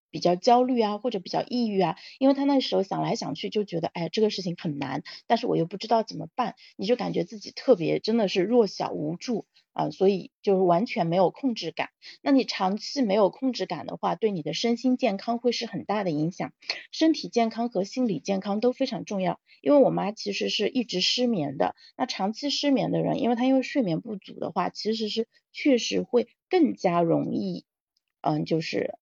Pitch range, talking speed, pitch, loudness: 185-250 Hz, 315 characters per minute, 220 Hz, -26 LUFS